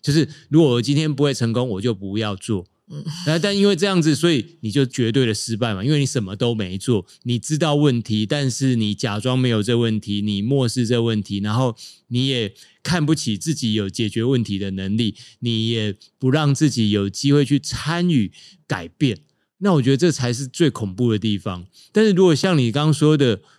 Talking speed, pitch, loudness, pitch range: 295 characters per minute, 125 Hz, -20 LUFS, 110-150 Hz